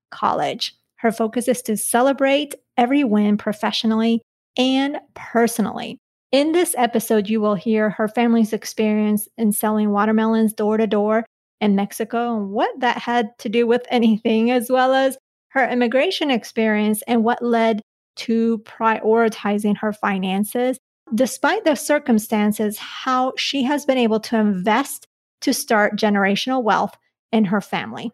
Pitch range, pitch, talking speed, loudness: 215-250 Hz, 230 Hz, 140 wpm, -19 LUFS